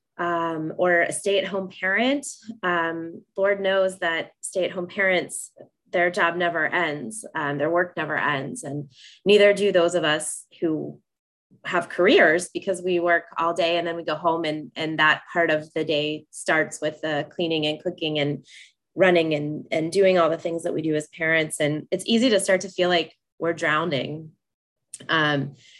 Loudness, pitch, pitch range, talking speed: -23 LUFS, 170 Hz, 155-185 Hz, 175 wpm